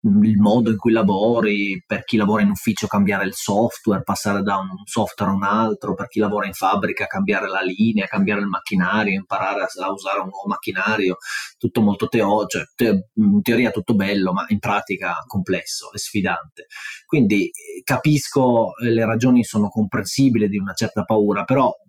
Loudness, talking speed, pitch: -20 LUFS, 175 wpm, 110 Hz